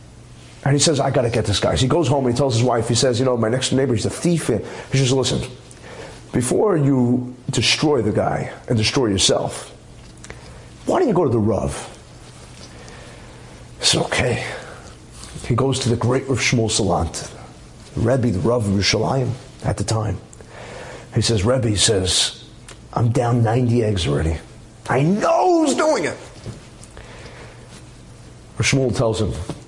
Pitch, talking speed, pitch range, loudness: 120 Hz, 170 wpm, 110-135 Hz, -19 LUFS